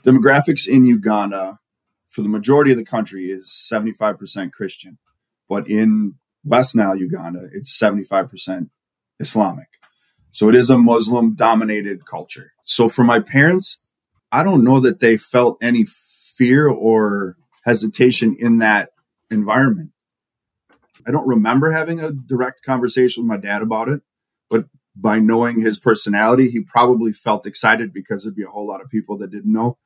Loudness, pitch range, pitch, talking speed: -16 LUFS, 105-125 Hz, 115 Hz, 155 wpm